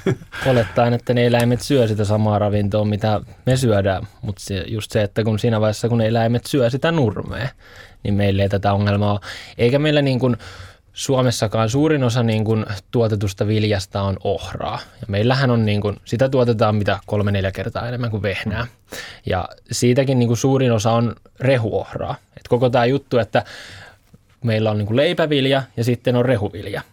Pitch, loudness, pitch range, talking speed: 110 Hz, -19 LUFS, 105-125 Hz, 170 wpm